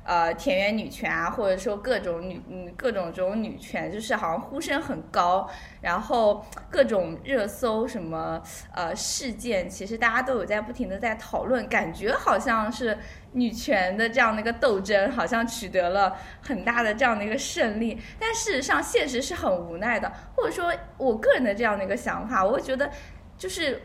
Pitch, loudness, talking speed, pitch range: 230 Hz, -26 LUFS, 280 characters per minute, 195-265 Hz